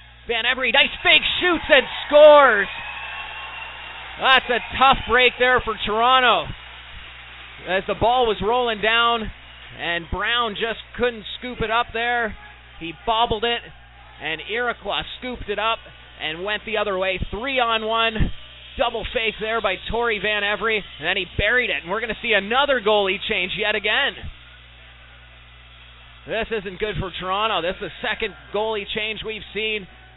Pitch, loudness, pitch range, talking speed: 215 Hz, -20 LUFS, 190-235 Hz, 155 wpm